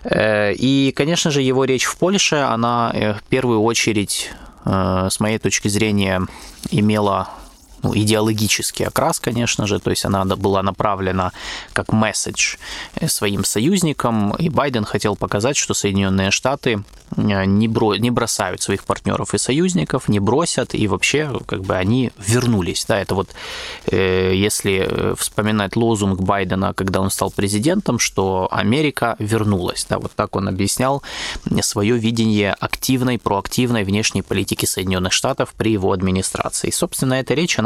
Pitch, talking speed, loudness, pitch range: 105 Hz, 140 wpm, -18 LUFS, 100-120 Hz